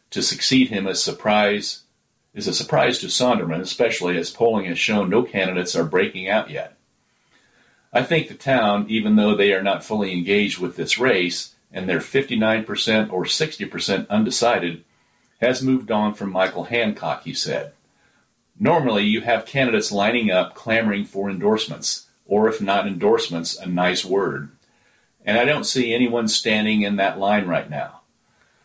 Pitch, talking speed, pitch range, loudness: 105 Hz, 160 wpm, 95-110 Hz, -20 LUFS